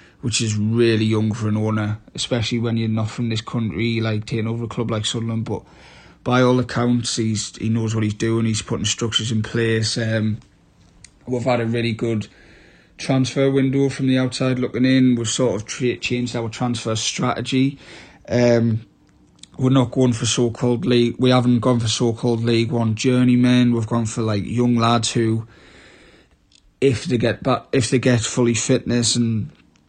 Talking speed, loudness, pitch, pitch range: 180 wpm, -20 LUFS, 115 Hz, 110-125 Hz